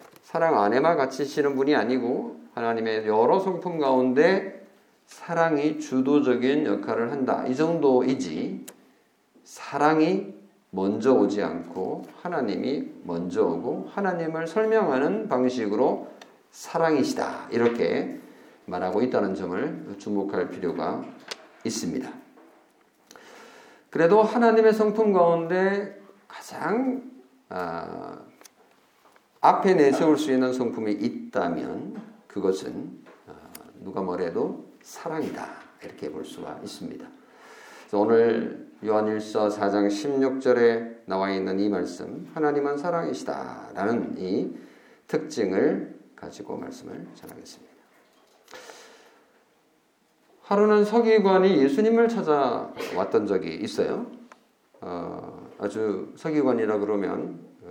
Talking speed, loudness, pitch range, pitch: 235 characters per minute, -25 LUFS, 115-190 Hz, 145 Hz